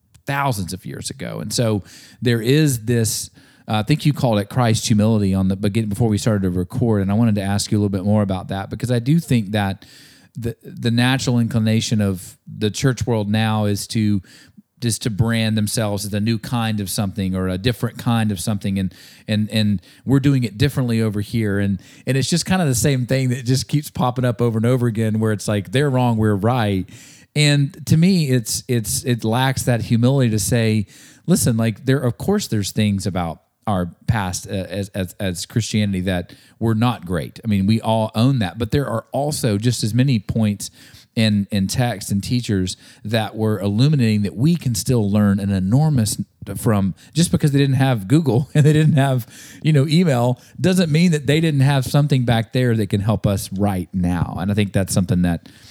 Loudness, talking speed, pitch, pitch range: -19 LUFS, 210 wpm, 115 Hz, 105-130 Hz